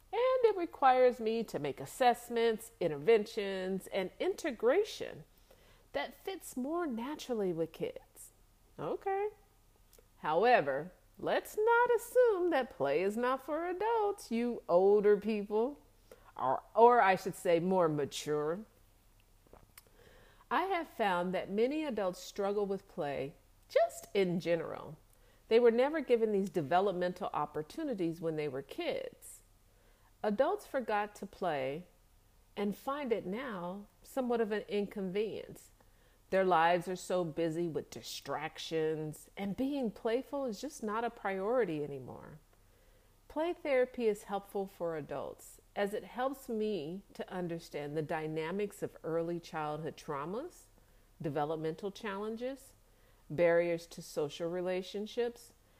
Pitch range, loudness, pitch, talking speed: 165-250 Hz, -34 LUFS, 205 Hz, 120 wpm